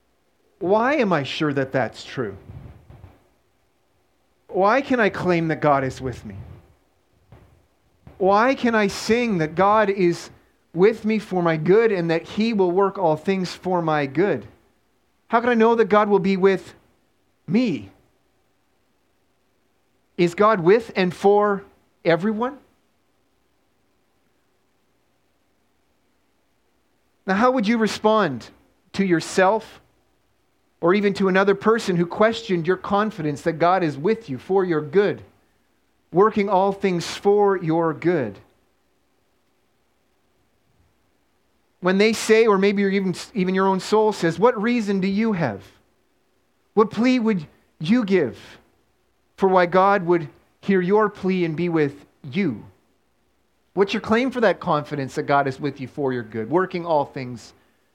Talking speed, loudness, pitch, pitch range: 135 wpm, -21 LUFS, 185 Hz, 145-205 Hz